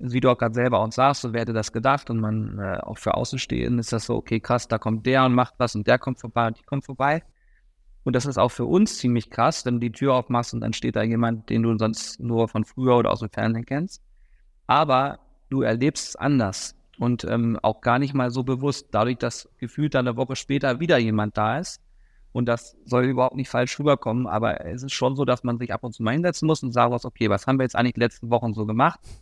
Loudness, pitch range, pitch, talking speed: -23 LUFS, 115-130 Hz, 120 Hz, 255 wpm